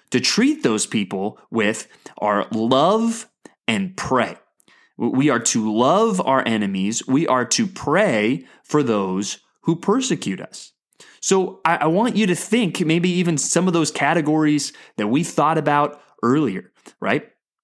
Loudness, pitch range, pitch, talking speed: -20 LUFS, 140-205 Hz, 165 Hz, 145 wpm